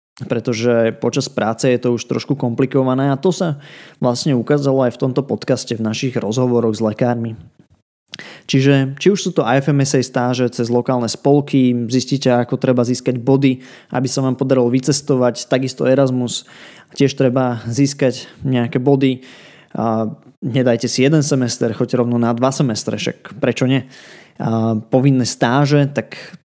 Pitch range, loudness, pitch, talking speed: 120-135 Hz, -17 LUFS, 130 Hz, 145 wpm